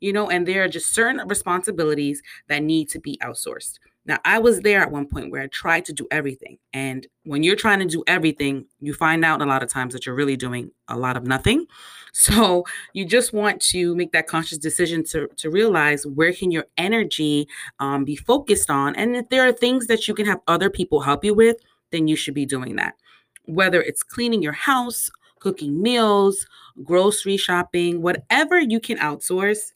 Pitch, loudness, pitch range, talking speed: 175 Hz, -20 LUFS, 145-210 Hz, 205 wpm